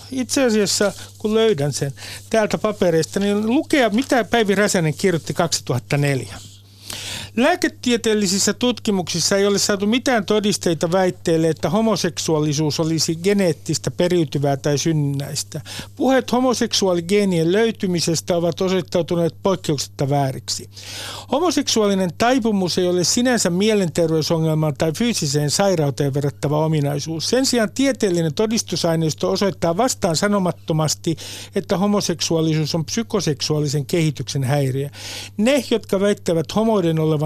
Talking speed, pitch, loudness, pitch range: 105 wpm, 175 Hz, -19 LUFS, 150-210 Hz